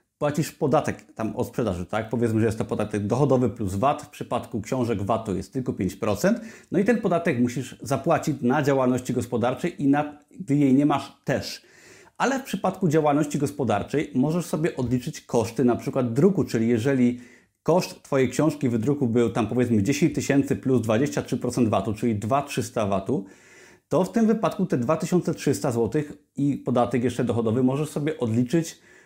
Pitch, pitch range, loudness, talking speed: 130 Hz, 120-150 Hz, -24 LUFS, 170 wpm